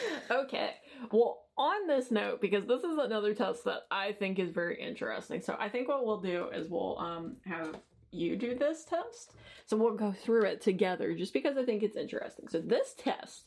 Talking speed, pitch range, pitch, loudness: 200 wpm, 205-285 Hz, 230 Hz, -33 LUFS